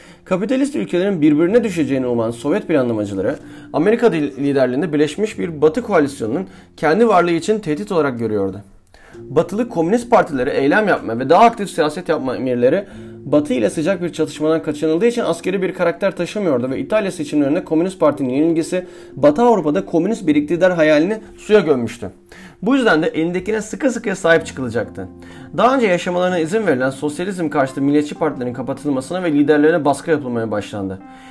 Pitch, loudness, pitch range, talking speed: 165 Hz, -17 LUFS, 140-200 Hz, 150 wpm